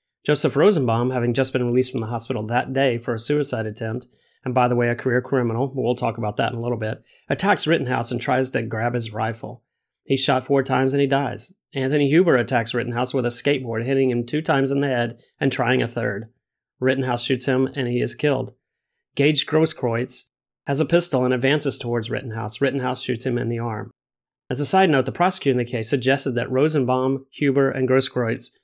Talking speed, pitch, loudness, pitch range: 210 wpm, 130 Hz, -21 LUFS, 120-135 Hz